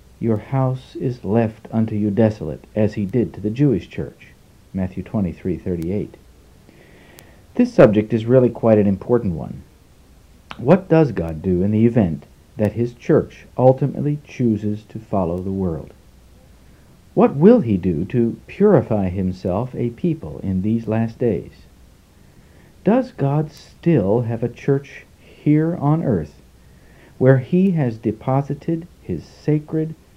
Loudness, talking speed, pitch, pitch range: -19 LUFS, 135 wpm, 110 Hz, 95-135 Hz